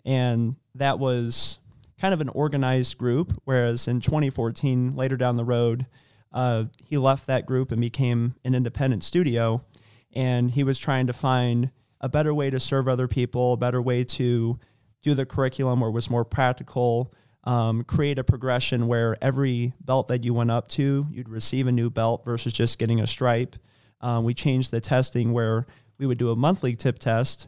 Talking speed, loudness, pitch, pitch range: 185 wpm, -24 LUFS, 125 Hz, 120-130 Hz